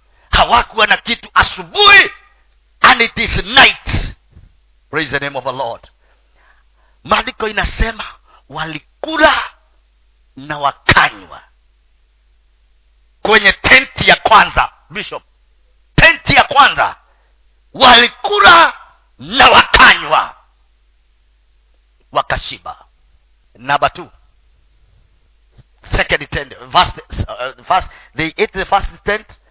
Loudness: -11 LUFS